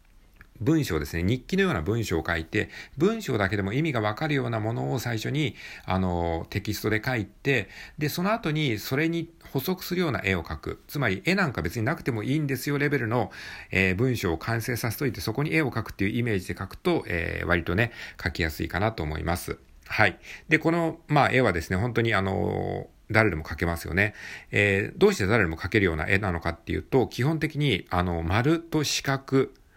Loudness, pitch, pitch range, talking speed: -26 LUFS, 110 Hz, 95-145 Hz, 405 characters per minute